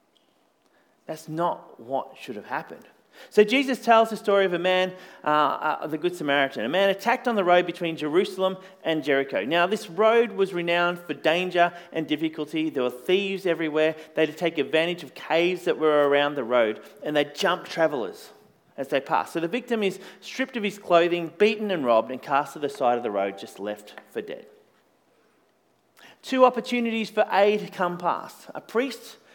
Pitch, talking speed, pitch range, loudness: 175 Hz, 190 wpm, 155-210 Hz, -24 LUFS